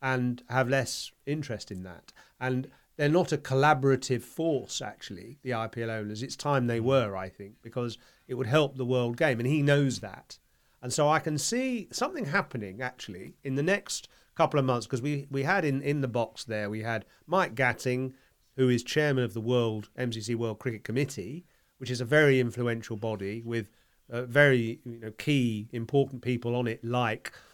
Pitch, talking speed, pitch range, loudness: 125 Hz, 185 wpm, 115-140 Hz, -29 LUFS